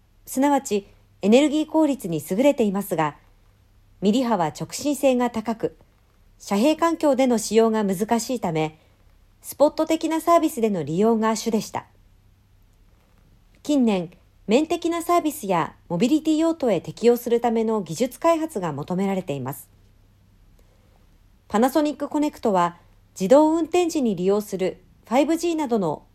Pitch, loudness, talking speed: 210 Hz, -22 LUFS, 285 characters per minute